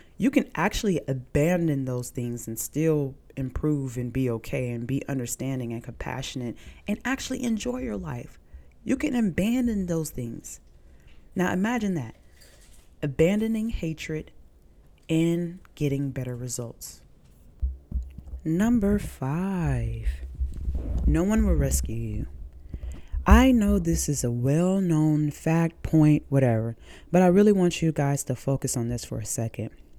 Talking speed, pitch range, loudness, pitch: 130 wpm, 110-170 Hz, -26 LUFS, 135 Hz